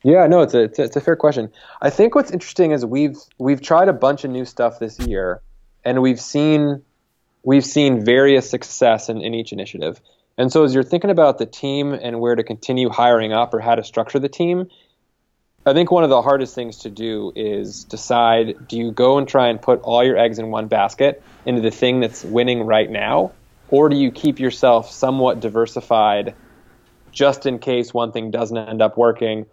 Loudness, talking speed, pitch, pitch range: -17 LUFS, 210 wpm, 125 Hz, 115-140 Hz